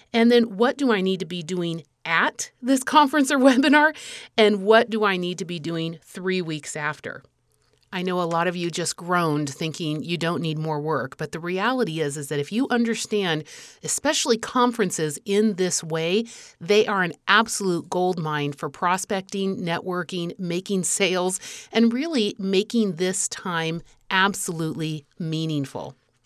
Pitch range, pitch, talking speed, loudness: 165-215 Hz, 185 Hz, 160 wpm, -23 LUFS